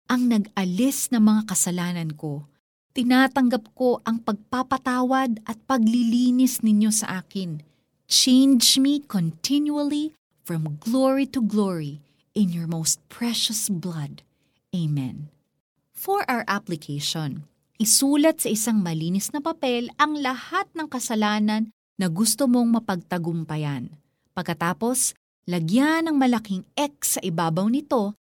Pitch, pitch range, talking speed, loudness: 220 Hz, 175-255 Hz, 110 wpm, -23 LUFS